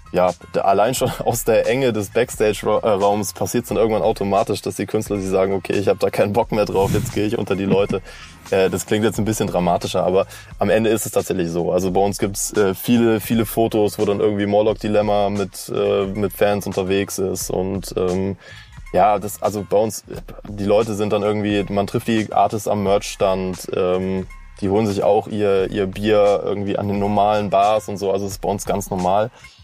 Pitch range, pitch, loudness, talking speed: 95-105 Hz, 100 Hz, -19 LUFS, 210 wpm